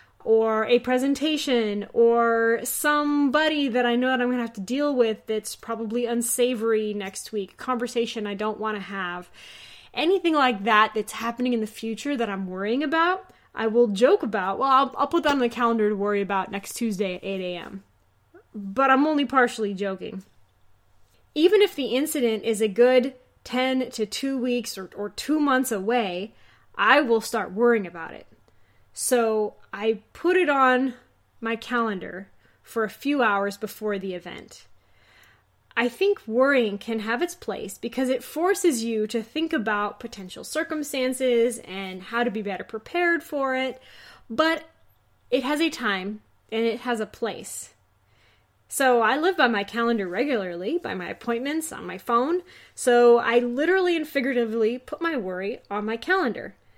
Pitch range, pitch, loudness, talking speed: 205-260 Hz, 235 Hz, -24 LUFS, 165 wpm